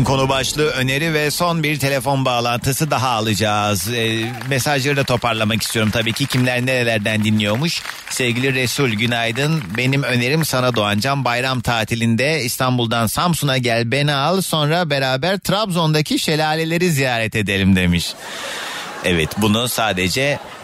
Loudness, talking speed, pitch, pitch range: -17 LUFS, 130 wpm, 130 Hz, 115-145 Hz